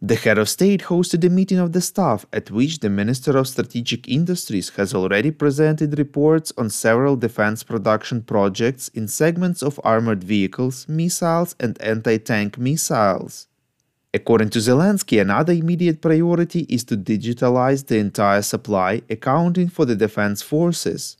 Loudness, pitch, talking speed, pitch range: -19 LUFS, 130 Hz, 150 wpm, 110-165 Hz